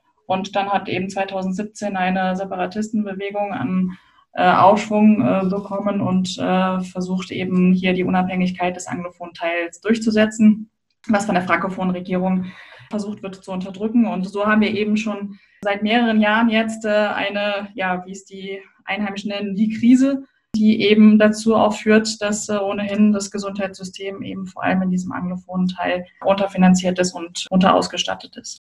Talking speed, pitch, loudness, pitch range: 155 wpm, 195 Hz, -19 LUFS, 185-210 Hz